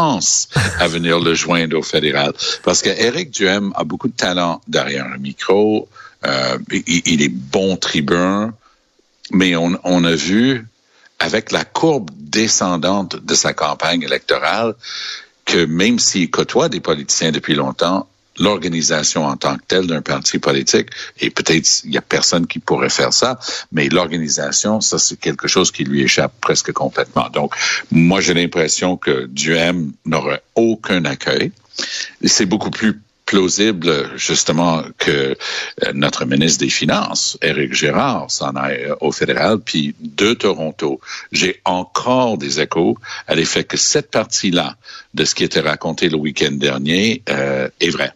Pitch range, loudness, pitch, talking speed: 80-100 Hz, -16 LUFS, 85 Hz, 150 wpm